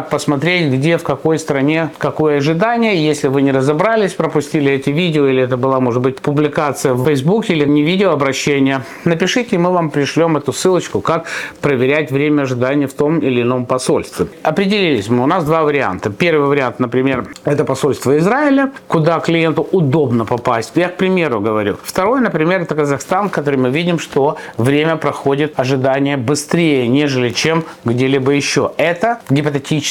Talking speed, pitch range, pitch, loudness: 165 wpm, 135-165 Hz, 150 Hz, -15 LUFS